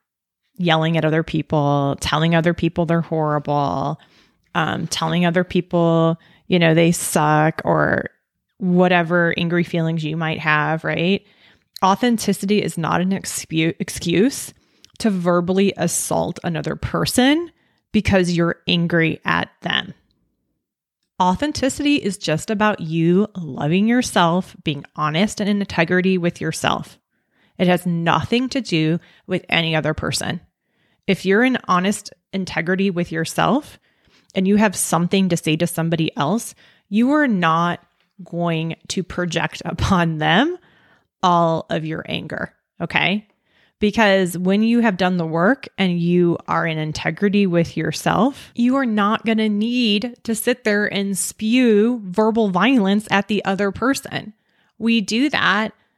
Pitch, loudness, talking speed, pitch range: 180 Hz, -19 LUFS, 135 wpm, 165-210 Hz